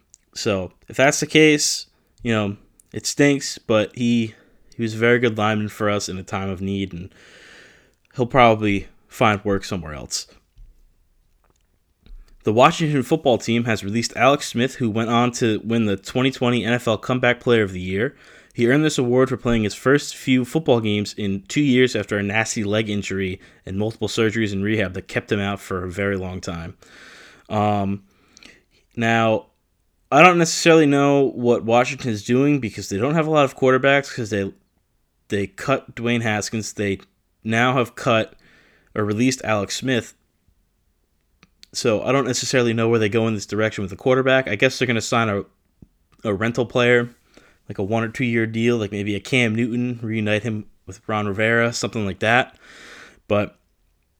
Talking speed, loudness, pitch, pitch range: 180 wpm, -20 LUFS, 110 Hz, 100-125 Hz